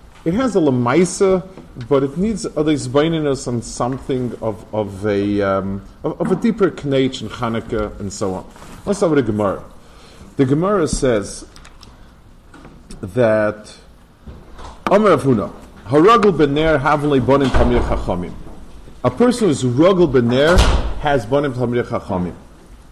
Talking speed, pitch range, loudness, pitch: 120 wpm, 110-155 Hz, -17 LUFS, 130 Hz